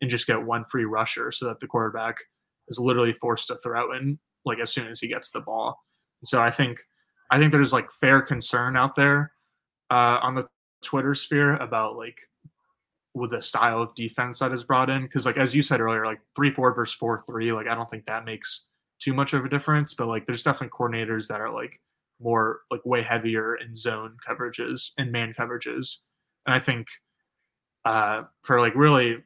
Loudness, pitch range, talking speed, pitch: -25 LUFS, 115-135 Hz, 205 wpm, 125 Hz